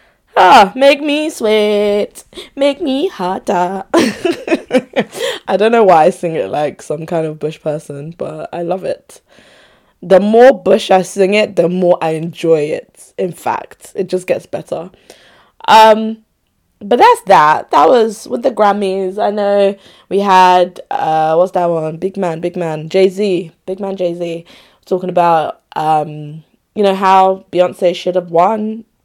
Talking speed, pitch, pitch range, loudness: 160 wpm, 190 Hz, 175-220 Hz, -13 LUFS